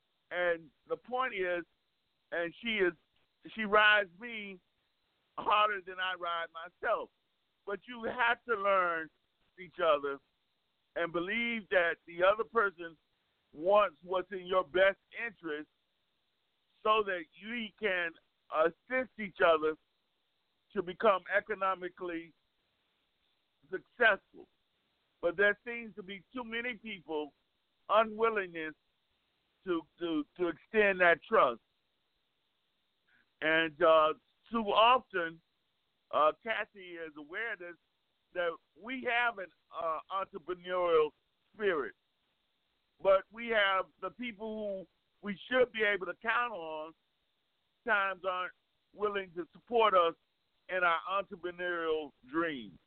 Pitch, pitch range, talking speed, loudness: 185 Hz, 170-215 Hz, 110 wpm, -32 LUFS